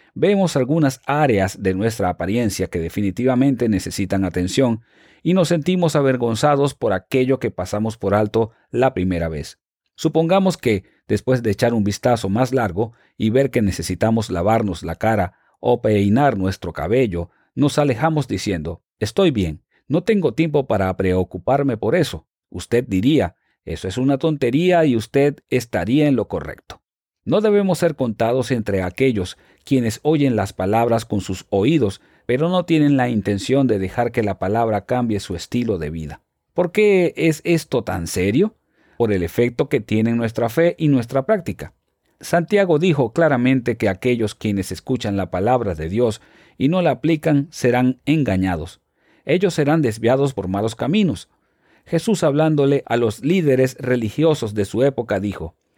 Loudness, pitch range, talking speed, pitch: -19 LUFS, 100-145 Hz, 155 wpm, 120 Hz